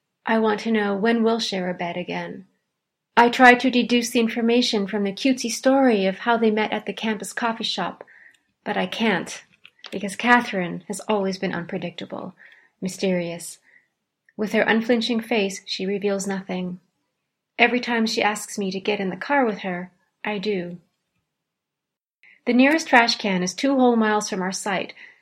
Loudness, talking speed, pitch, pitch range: -22 LUFS, 170 wpm, 210 Hz, 190-235 Hz